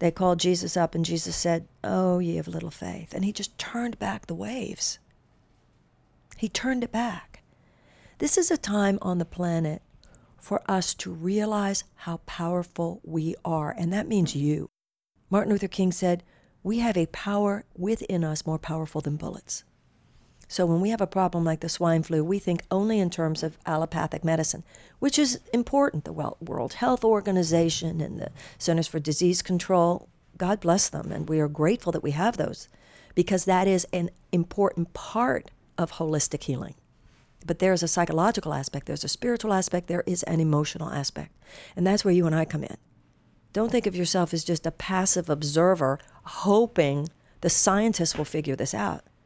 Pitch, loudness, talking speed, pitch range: 175 Hz, -26 LUFS, 175 wpm, 160-195 Hz